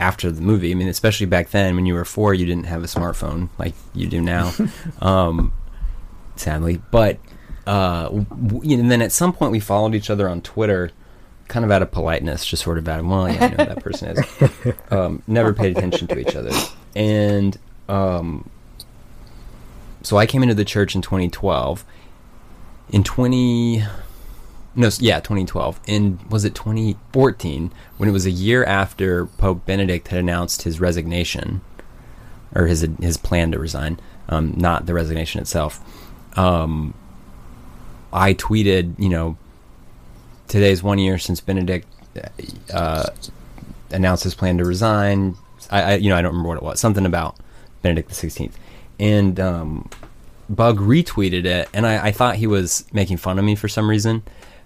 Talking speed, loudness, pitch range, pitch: 170 wpm, -19 LUFS, 85-105 Hz, 95 Hz